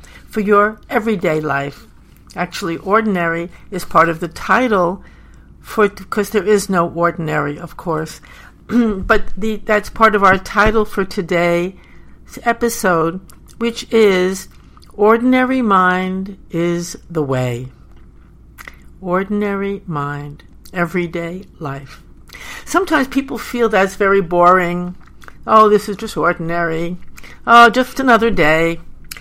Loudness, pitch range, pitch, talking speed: -16 LUFS, 170-215 Hz, 190 Hz, 115 wpm